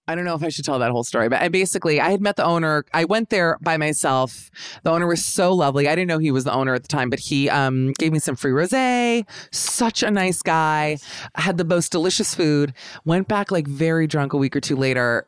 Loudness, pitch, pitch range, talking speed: -20 LUFS, 160 Hz, 140-180 Hz, 260 wpm